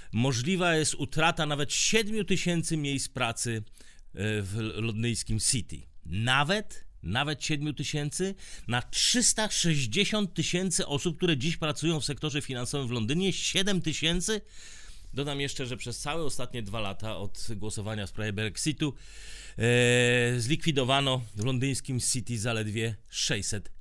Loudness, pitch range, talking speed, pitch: -28 LUFS, 115-160 Hz, 120 wpm, 135 Hz